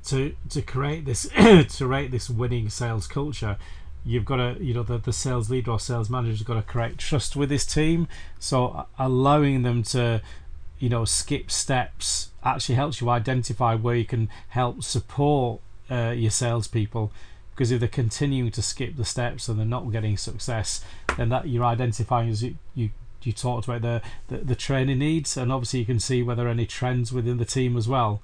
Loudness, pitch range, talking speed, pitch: -25 LUFS, 115-130 Hz, 195 wpm, 120 Hz